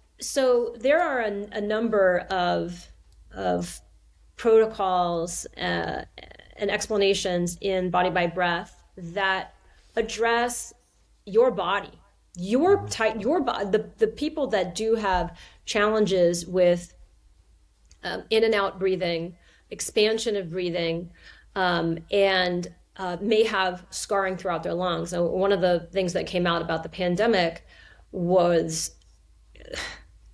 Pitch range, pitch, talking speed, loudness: 175-215 Hz, 185 Hz, 120 wpm, -25 LUFS